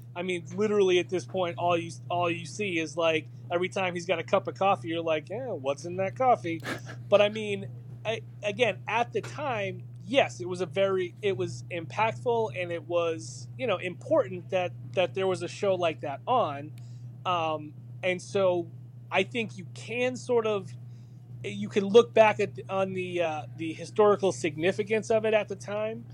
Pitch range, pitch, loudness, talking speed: 125-195 Hz, 170 Hz, -28 LUFS, 195 wpm